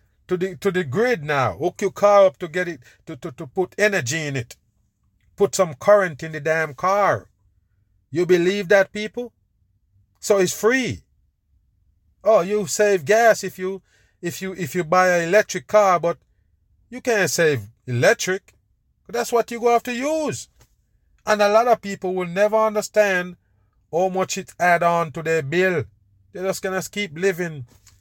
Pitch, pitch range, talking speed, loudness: 180 Hz, 125-205 Hz, 175 wpm, -20 LUFS